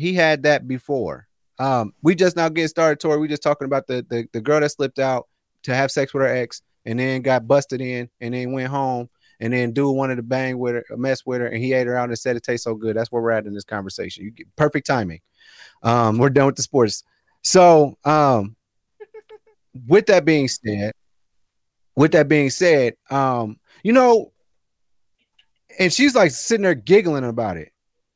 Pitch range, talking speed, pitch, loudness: 120-150 Hz, 205 wpm, 130 Hz, -19 LUFS